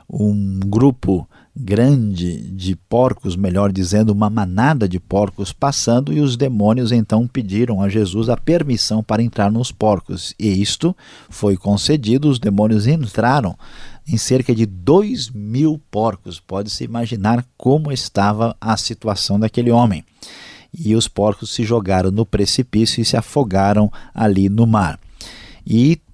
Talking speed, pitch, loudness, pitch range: 140 wpm, 110 Hz, -17 LUFS, 100-120 Hz